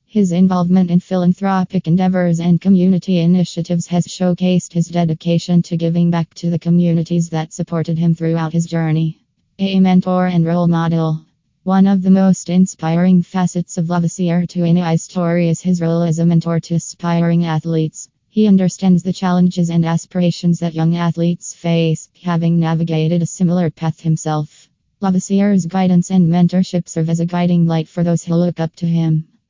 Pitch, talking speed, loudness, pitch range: 170 Hz, 165 wpm, -16 LUFS, 165-180 Hz